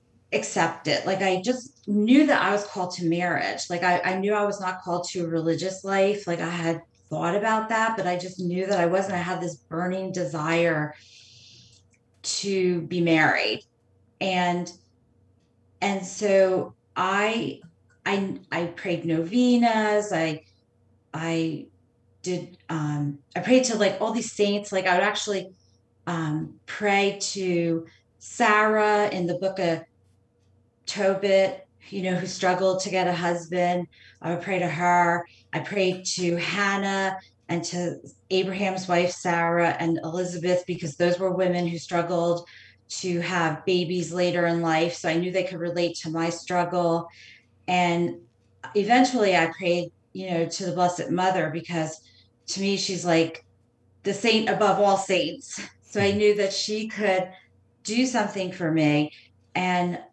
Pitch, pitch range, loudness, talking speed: 175 Hz, 165-190 Hz, -25 LUFS, 155 wpm